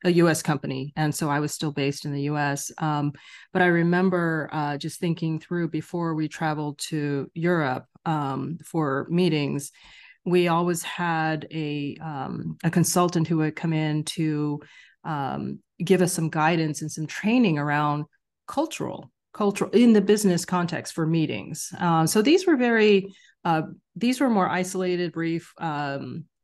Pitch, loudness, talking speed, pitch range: 160 Hz, -25 LUFS, 155 wpm, 150-180 Hz